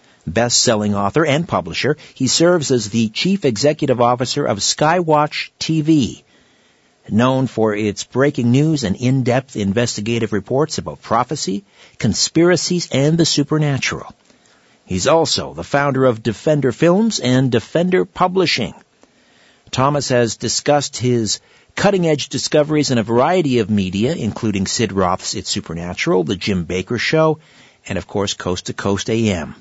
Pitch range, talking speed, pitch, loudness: 110-150 Hz, 140 wpm, 125 Hz, -17 LUFS